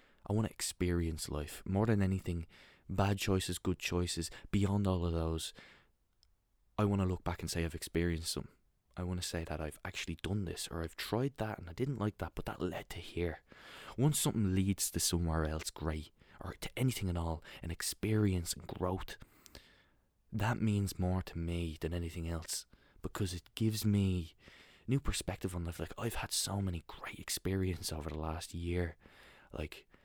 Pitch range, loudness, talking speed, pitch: 85-100 Hz, -37 LUFS, 185 wpm, 90 Hz